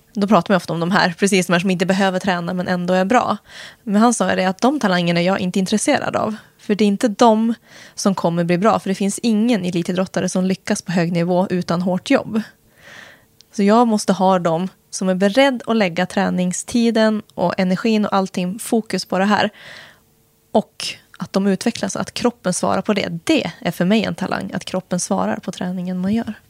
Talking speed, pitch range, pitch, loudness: 210 wpm, 185-215 Hz, 195 Hz, -18 LUFS